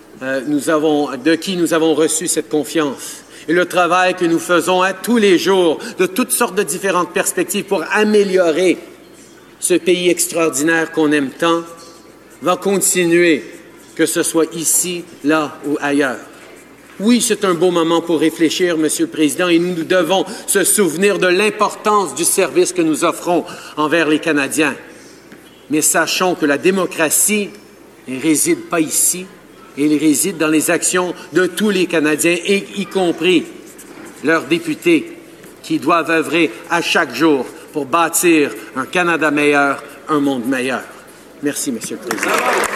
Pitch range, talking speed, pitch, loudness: 155-190 Hz, 155 wpm, 170 Hz, -15 LUFS